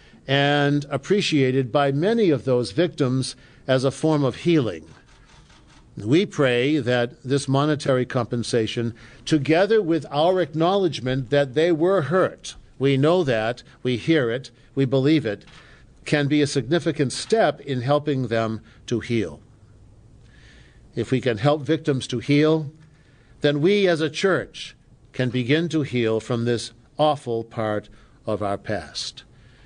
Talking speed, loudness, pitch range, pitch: 140 wpm, -22 LUFS, 120-155 Hz, 135 Hz